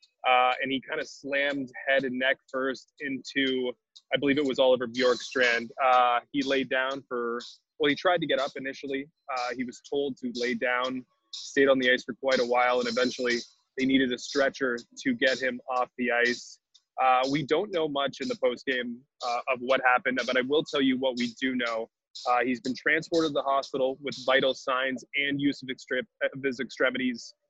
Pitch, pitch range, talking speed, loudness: 130 Hz, 125-140 Hz, 205 wpm, -27 LUFS